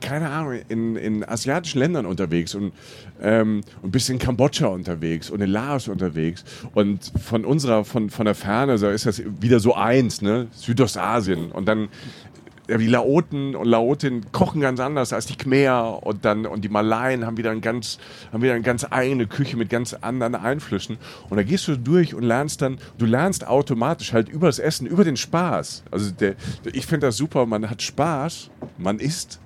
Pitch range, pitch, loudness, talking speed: 105-135 Hz, 120 Hz, -22 LUFS, 185 wpm